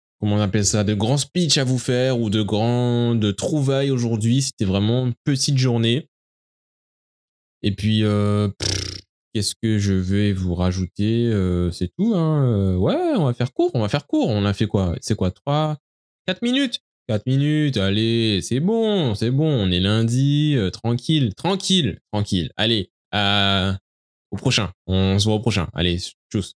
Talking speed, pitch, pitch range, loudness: 180 wpm, 110 Hz, 100-135 Hz, -20 LUFS